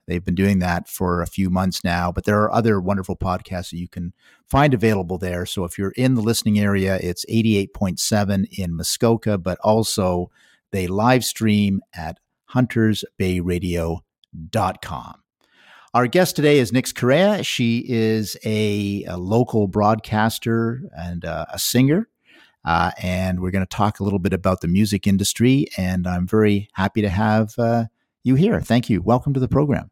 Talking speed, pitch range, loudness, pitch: 165 wpm, 90-115 Hz, -20 LUFS, 100 Hz